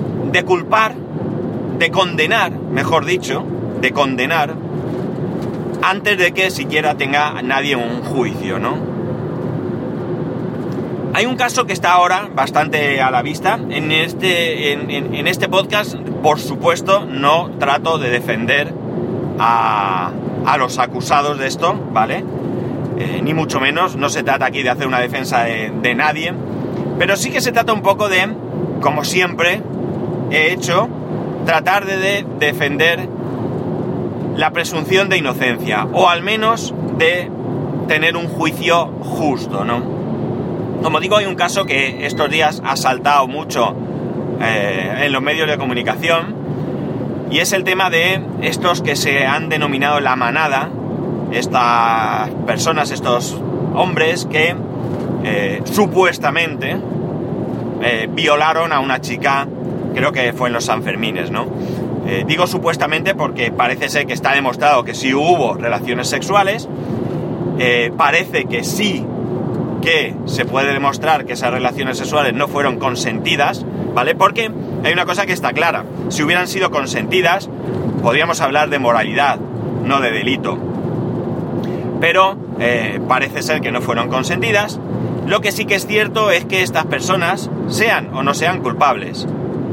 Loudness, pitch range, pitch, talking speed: -16 LUFS, 135-185 Hz, 155 Hz, 140 wpm